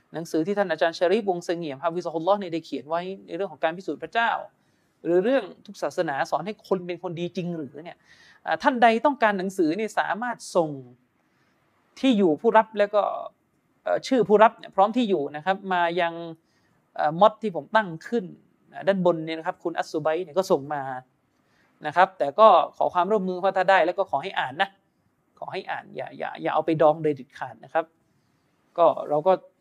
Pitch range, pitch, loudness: 160-205 Hz, 180 Hz, -24 LUFS